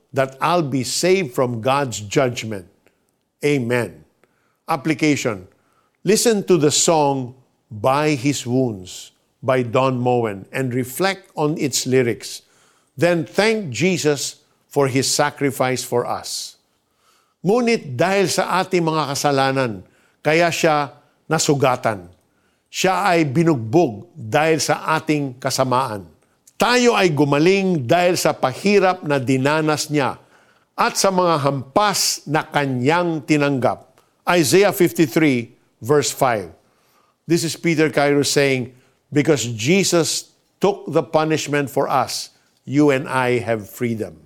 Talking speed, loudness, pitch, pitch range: 115 wpm, -19 LUFS, 145 Hz, 130-165 Hz